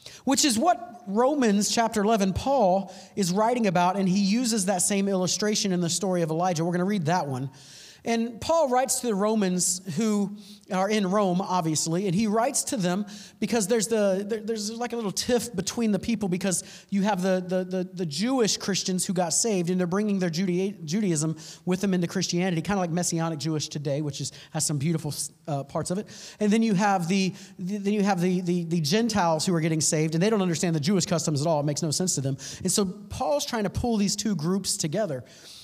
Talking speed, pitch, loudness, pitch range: 220 wpm, 190 Hz, -25 LUFS, 175-210 Hz